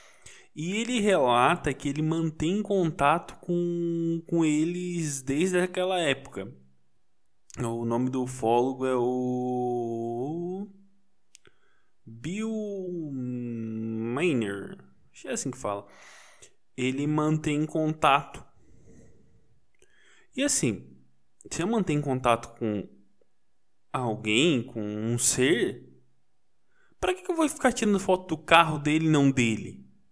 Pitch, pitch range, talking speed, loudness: 140 Hz, 115-175 Hz, 105 wpm, -27 LUFS